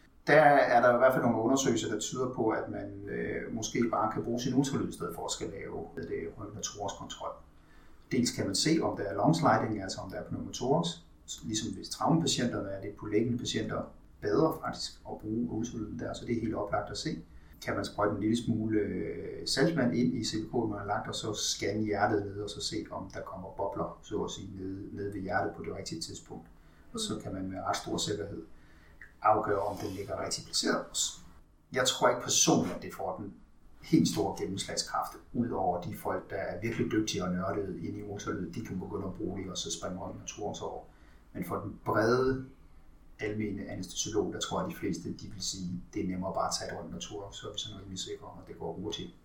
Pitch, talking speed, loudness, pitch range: 100 Hz, 225 wpm, -32 LUFS, 95-105 Hz